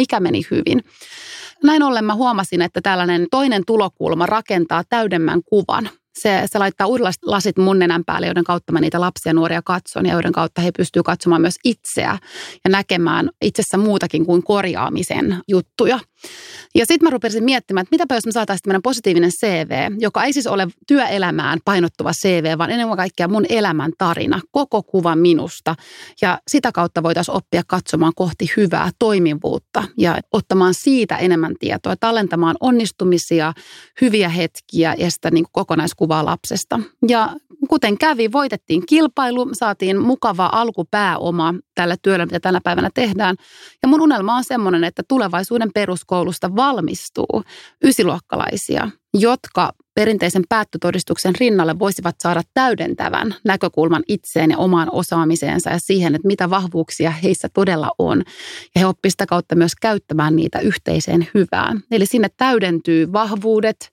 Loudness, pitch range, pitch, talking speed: -17 LUFS, 170-225 Hz, 190 Hz, 145 wpm